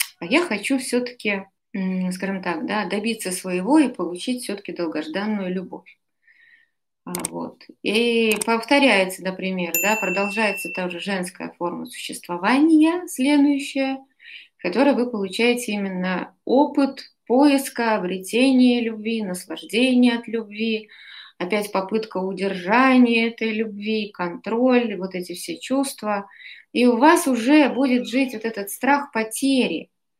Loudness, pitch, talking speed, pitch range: -21 LUFS, 225 Hz, 115 wpm, 190-260 Hz